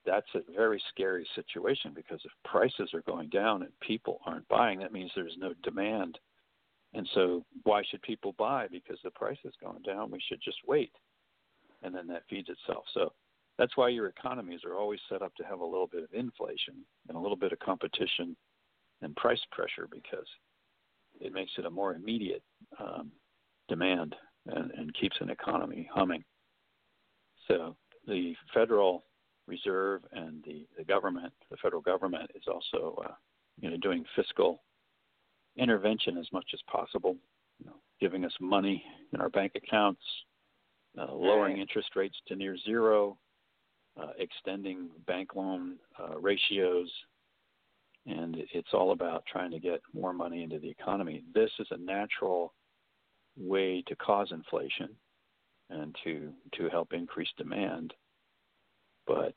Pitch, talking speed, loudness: 105 Hz, 155 wpm, -34 LUFS